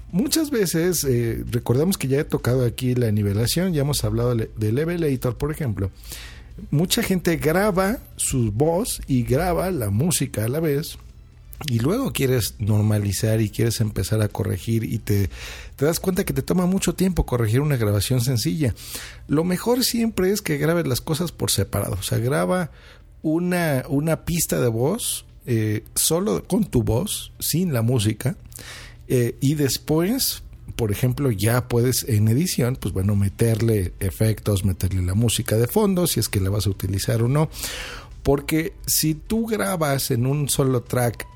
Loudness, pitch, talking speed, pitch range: -22 LUFS, 130 Hz, 165 wpm, 110-160 Hz